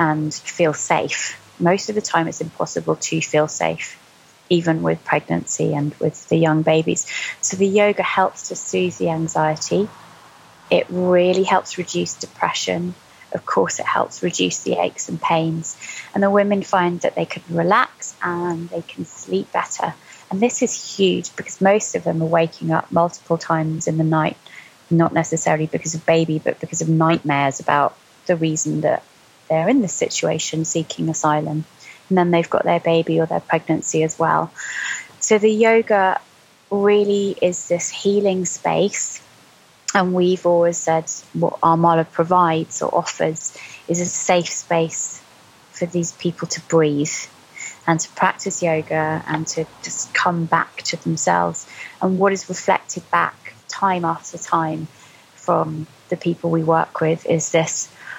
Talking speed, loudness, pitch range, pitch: 160 wpm, -20 LUFS, 160-185 Hz, 165 Hz